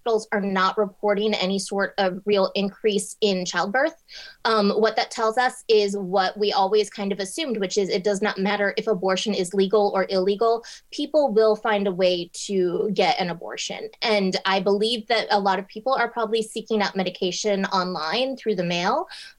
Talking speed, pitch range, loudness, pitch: 185 wpm, 195-220 Hz, -23 LUFS, 205 Hz